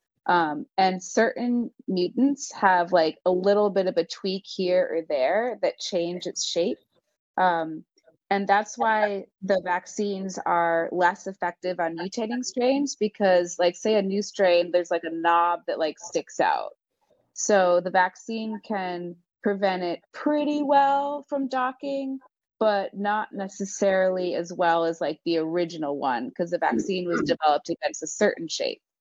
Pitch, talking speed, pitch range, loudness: 190 Hz, 155 wpm, 175-220 Hz, -25 LUFS